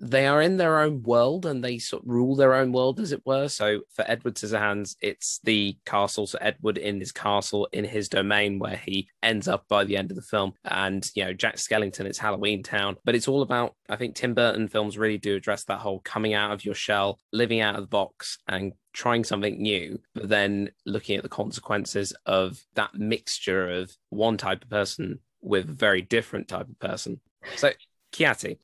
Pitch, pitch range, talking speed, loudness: 105 Hz, 100-120 Hz, 210 wpm, -26 LUFS